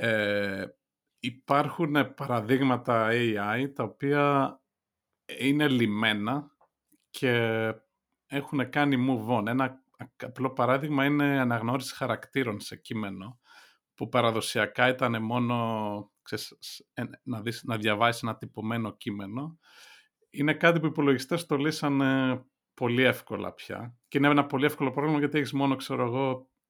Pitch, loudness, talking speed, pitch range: 130 Hz, -28 LUFS, 120 wpm, 115-140 Hz